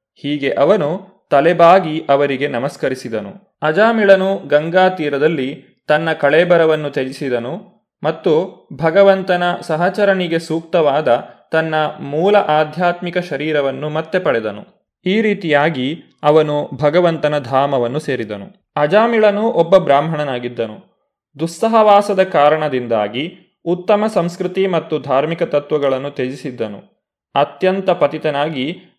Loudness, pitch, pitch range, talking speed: -16 LUFS, 155 Hz, 140-180 Hz, 85 wpm